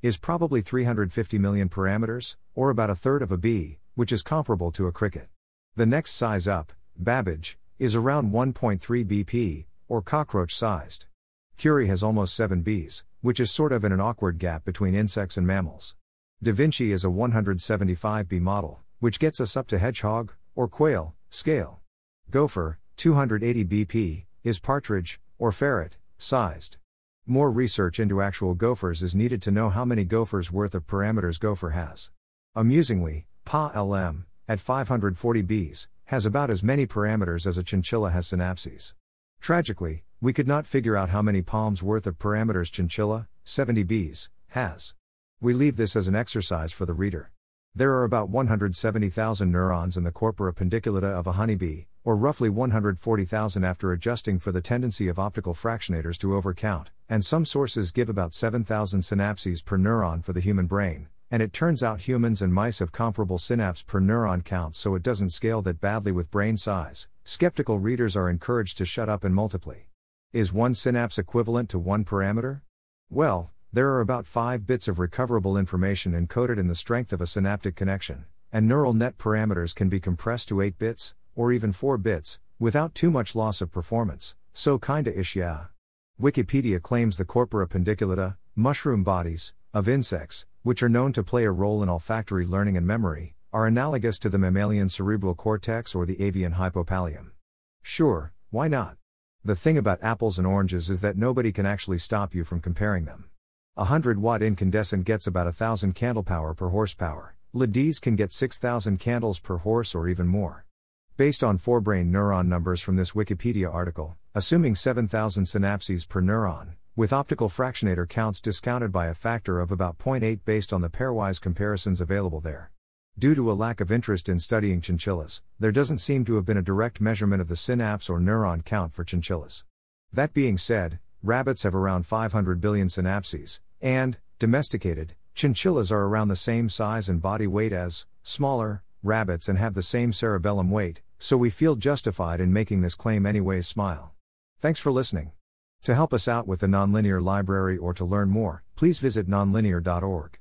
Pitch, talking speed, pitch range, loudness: 100 Hz, 175 wpm, 90-115 Hz, -26 LUFS